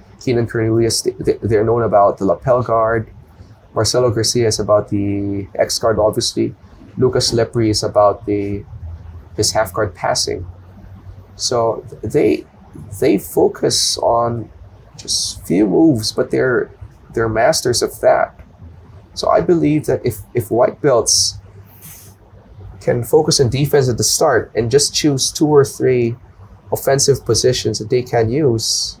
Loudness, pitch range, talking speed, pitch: -16 LUFS, 100-120 Hz, 140 wpm, 110 Hz